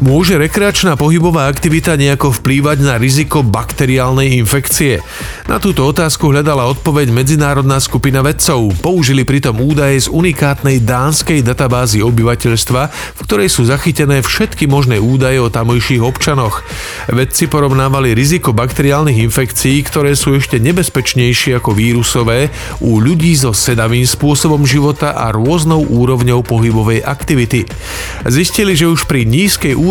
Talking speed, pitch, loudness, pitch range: 125 wpm, 135 Hz, -11 LUFS, 120-150 Hz